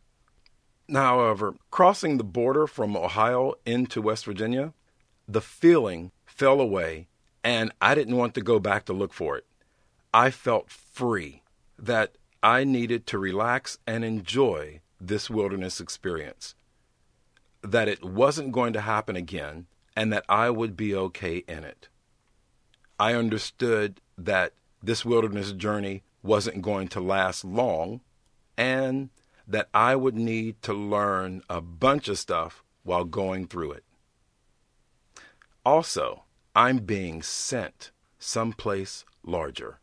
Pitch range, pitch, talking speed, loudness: 95-120 Hz, 110 Hz, 130 wpm, -26 LUFS